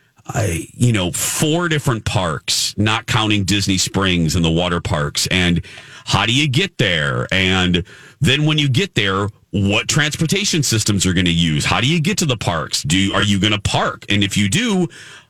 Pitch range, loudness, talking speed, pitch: 95-145 Hz, -17 LUFS, 190 wpm, 105 Hz